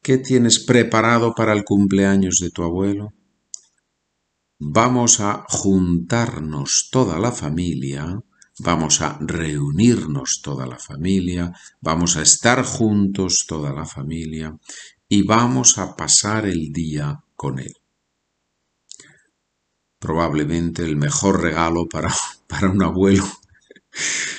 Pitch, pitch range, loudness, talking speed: 85 Hz, 75-105 Hz, -18 LUFS, 110 wpm